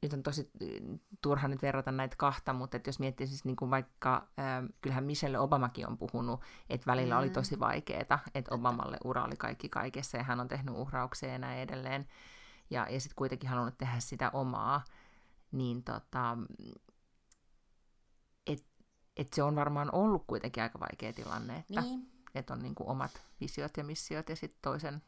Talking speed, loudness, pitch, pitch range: 170 wpm, -37 LUFS, 130 Hz, 125-145 Hz